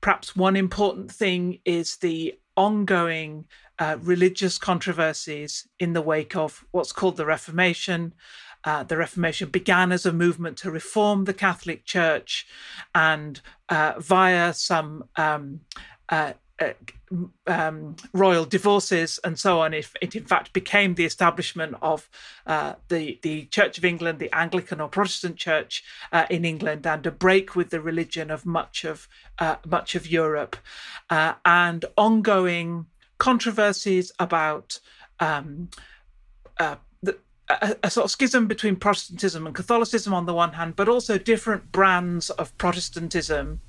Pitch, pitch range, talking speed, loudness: 175 Hz, 160-195 Hz, 145 wpm, -23 LUFS